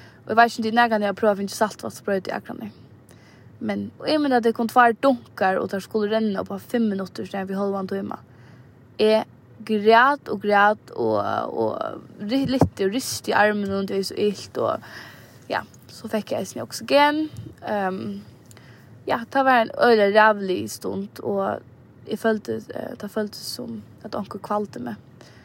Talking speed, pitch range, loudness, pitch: 185 wpm, 180-225 Hz, -22 LUFS, 205 Hz